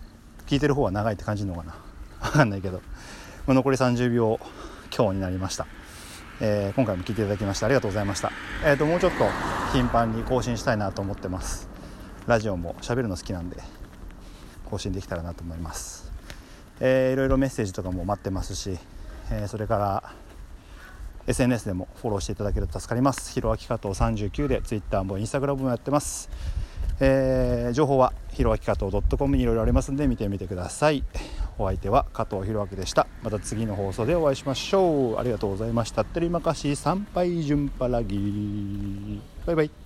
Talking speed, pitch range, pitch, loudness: 405 characters per minute, 95-130 Hz, 105 Hz, -26 LUFS